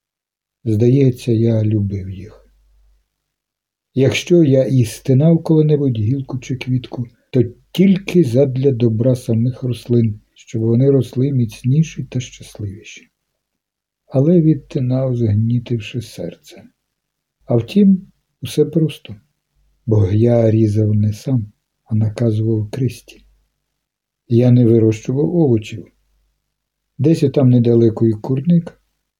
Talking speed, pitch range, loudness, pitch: 100 wpm, 115-140 Hz, -16 LUFS, 125 Hz